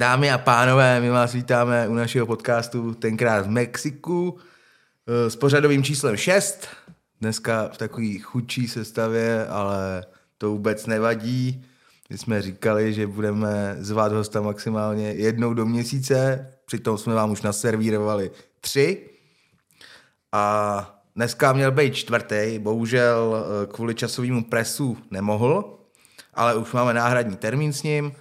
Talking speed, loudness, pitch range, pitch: 125 wpm, -23 LUFS, 110-125 Hz, 115 Hz